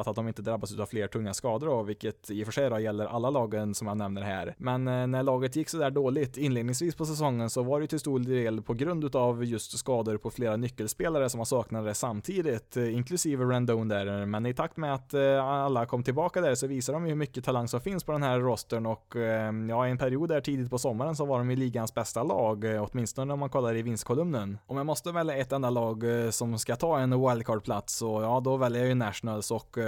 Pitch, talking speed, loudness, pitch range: 120 Hz, 225 wpm, -30 LUFS, 110-135 Hz